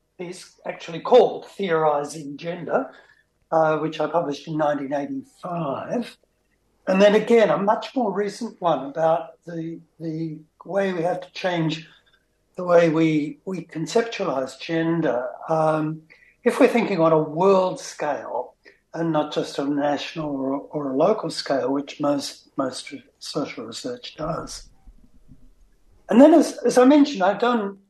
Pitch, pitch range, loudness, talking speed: 165 Hz, 155-195 Hz, -22 LUFS, 140 wpm